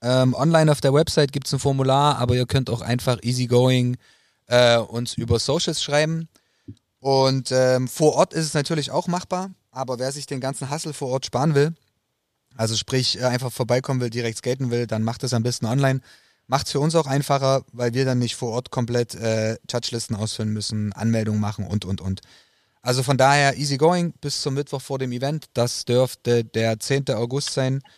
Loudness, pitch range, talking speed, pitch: -22 LUFS, 120-140 Hz, 190 wpm, 130 Hz